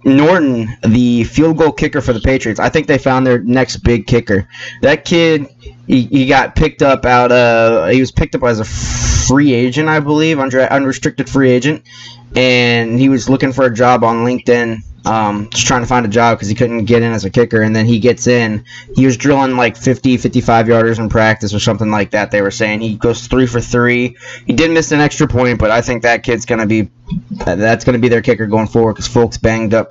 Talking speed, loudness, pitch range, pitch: 230 wpm, -12 LUFS, 115-130 Hz, 120 Hz